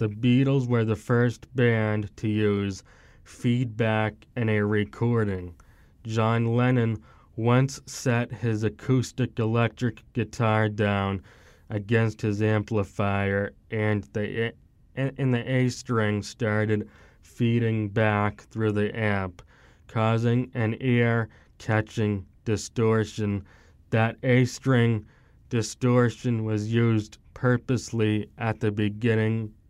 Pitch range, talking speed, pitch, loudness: 105-120 Hz, 95 wpm, 110 Hz, -26 LUFS